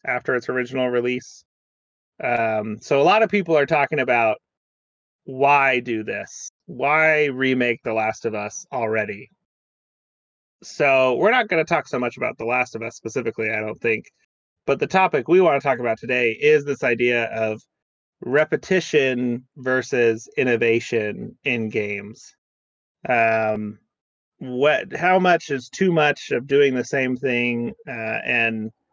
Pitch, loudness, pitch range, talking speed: 120 Hz, -21 LUFS, 110-140 Hz, 150 wpm